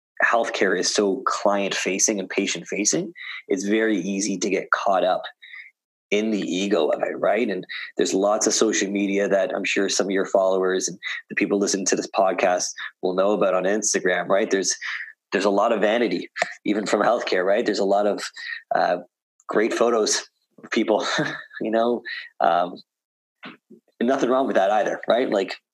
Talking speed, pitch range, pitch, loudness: 175 wpm, 100-105 Hz, 100 Hz, -22 LUFS